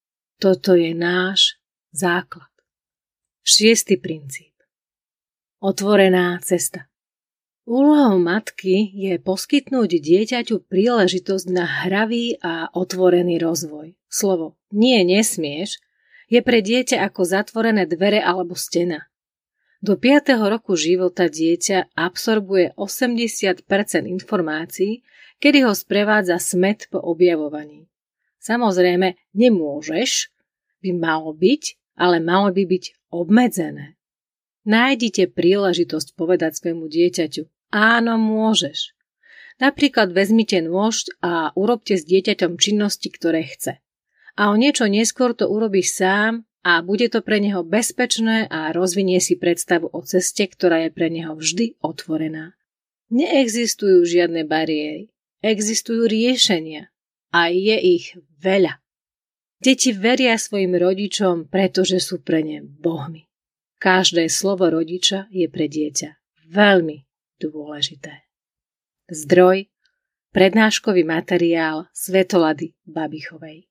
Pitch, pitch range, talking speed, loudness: 185 Hz, 170-220 Hz, 105 wpm, -18 LUFS